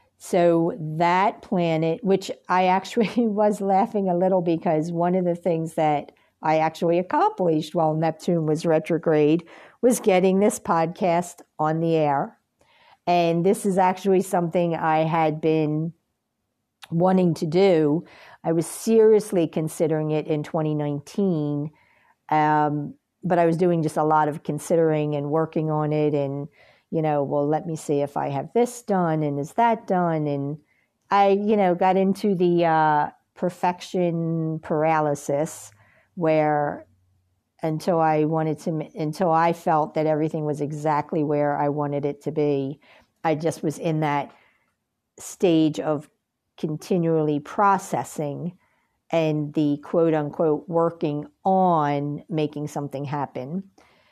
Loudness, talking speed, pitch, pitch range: -23 LUFS, 135 wpm, 160 Hz, 150-180 Hz